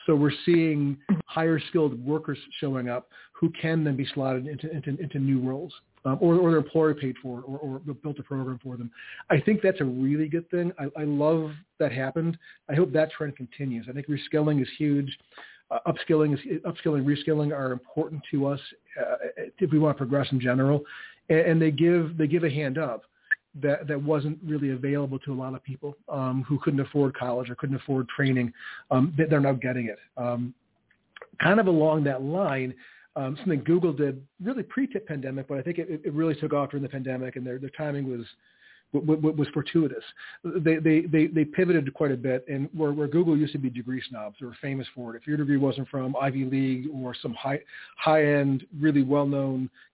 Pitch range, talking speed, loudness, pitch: 135-155 Hz, 210 wpm, -27 LUFS, 145 Hz